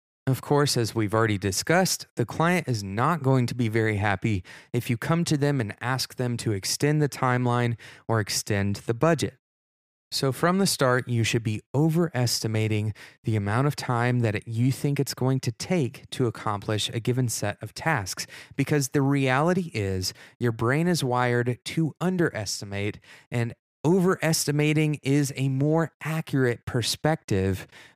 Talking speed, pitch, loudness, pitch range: 160 wpm, 125 Hz, -26 LUFS, 110-145 Hz